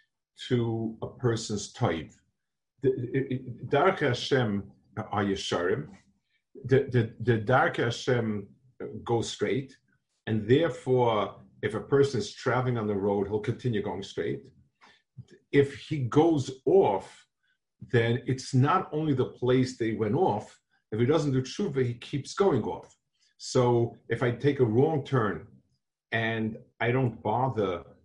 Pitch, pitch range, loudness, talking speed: 125 Hz, 115-135 Hz, -28 LUFS, 130 wpm